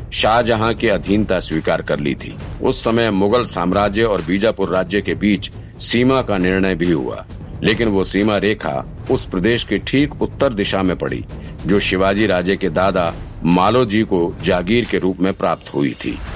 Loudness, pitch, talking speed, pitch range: -17 LUFS, 100 Hz, 170 wpm, 95-115 Hz